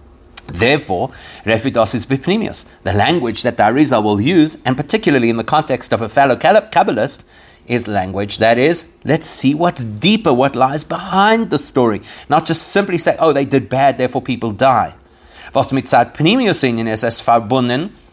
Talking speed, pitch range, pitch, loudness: 135 wpm, 115-155 Hz, 130 Hz, -14 LUFS